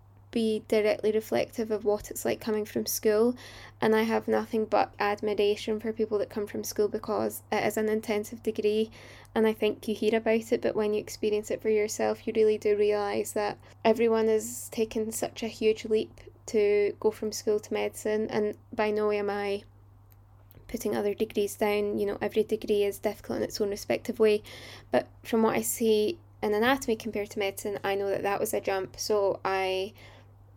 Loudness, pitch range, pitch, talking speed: -29 LUFS, 205-220 Hz, 215 Hz, 195 wpm